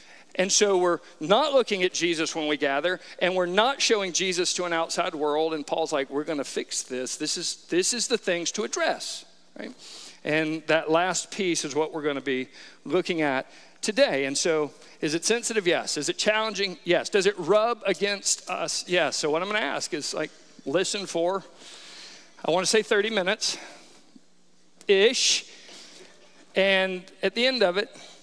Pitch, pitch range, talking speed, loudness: 180 Hz, 160-210 Hz, 185 wpm, -25 LUFS